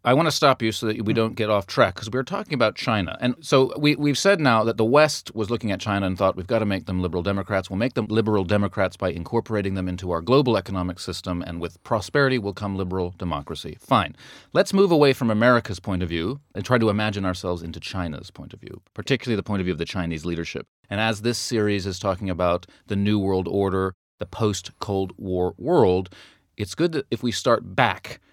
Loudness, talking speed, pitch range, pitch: -23 LUFS, 235 wpm, 95-120 Hz, 105 Hz